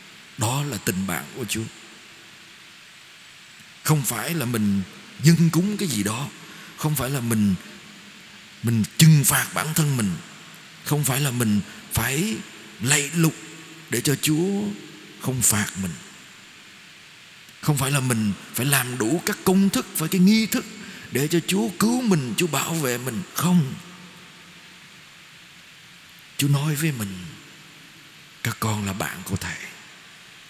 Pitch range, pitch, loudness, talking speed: 125-180 Hz, 155 Hz, -23 LUFS, 140 wpm